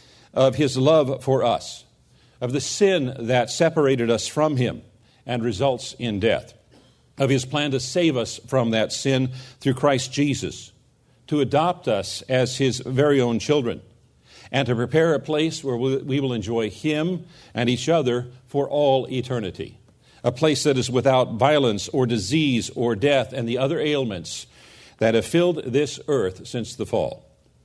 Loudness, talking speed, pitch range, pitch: -22 LUFS, 165 wpm, 120-145 Hz, 130 Hz